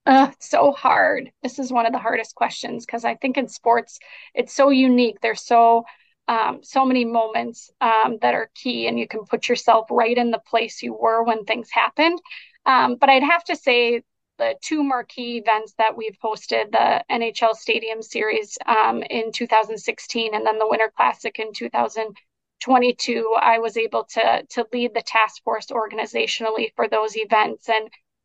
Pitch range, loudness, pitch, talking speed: 220-255 Hz, -20 LUFS, 230 Hz, 175 wpm